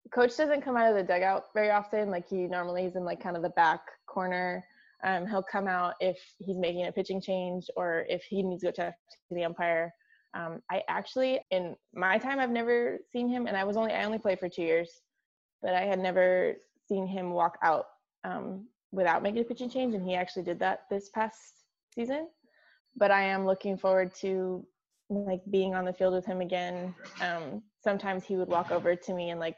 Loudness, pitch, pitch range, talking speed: -31 LUFS, 190 Hz, 180-215 Hz, 215 wpm